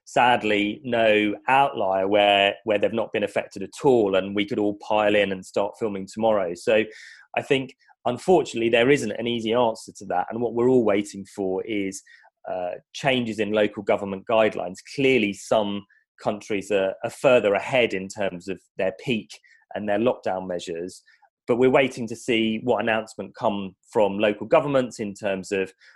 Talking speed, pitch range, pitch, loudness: 175 wpm, 100-120 Hz, 105 Hz, -23 LUFS